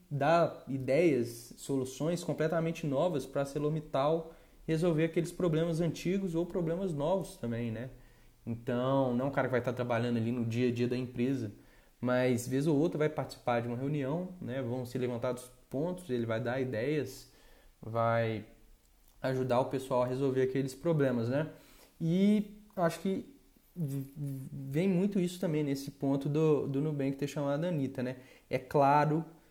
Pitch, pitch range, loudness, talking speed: 140 Hz, 125-165 Hz, -33 LUFS, 165 wpm